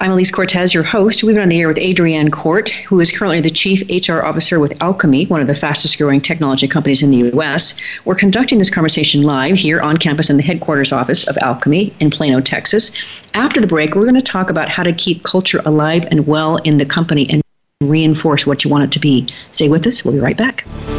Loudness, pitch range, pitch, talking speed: -12 LUFS, 150-185 Hz, 160 Hz, 235 wpm